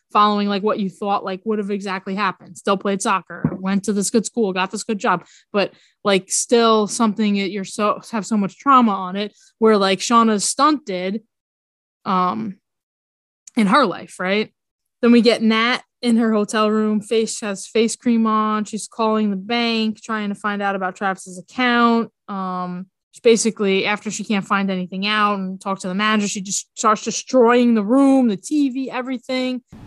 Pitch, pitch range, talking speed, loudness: 210 Hz, 195-230 Hz, 185 wpm, -19 LUFS